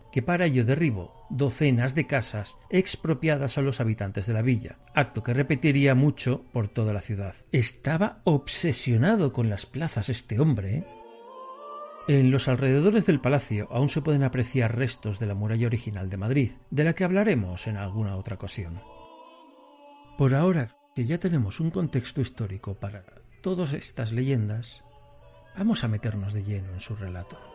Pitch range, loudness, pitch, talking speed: 110-150 Hz, -26 LUFS, 130 Hz, 160 wpm